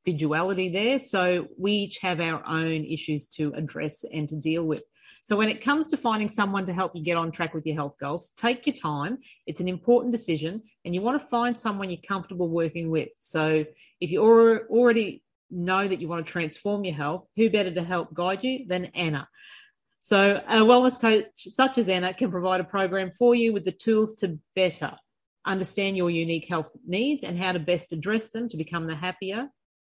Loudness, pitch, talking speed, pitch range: -26 LUFS, 185 Hz, 205 wpm, 165-225 Hz